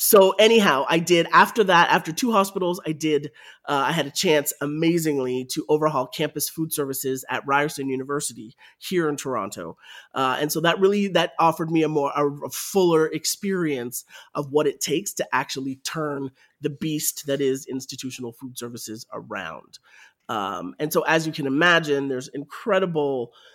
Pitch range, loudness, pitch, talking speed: 135-165 Hz, -22 LUFS, 150 Hz, 170 wpm